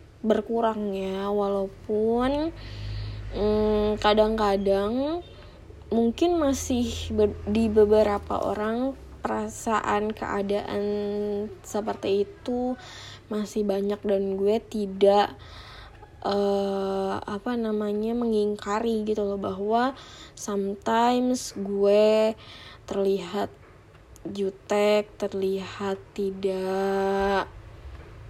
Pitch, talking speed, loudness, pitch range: 205 Hz, 70 wpm, -26 LUFS, 195-215 Hz